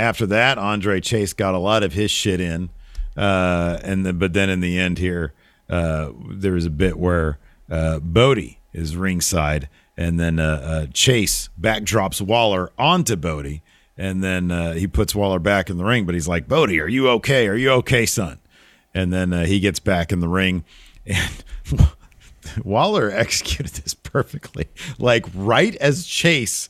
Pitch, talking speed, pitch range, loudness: 90 Hz, 175 wpm, 85-105 Hz, -20 LUFS